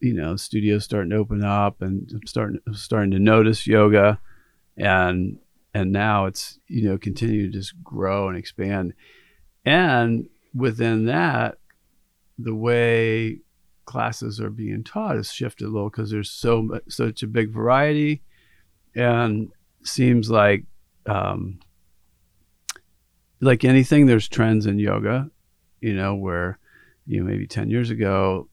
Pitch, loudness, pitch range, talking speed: 110 Hz, -21 LUFS, 100-115 Hz, 140 wpm